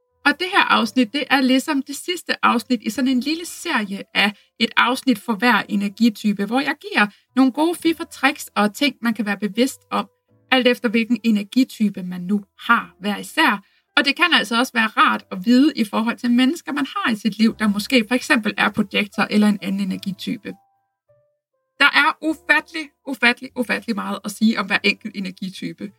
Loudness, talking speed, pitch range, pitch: -19 LUFS, 195 wpm, 210-275 Hz, 245 Hz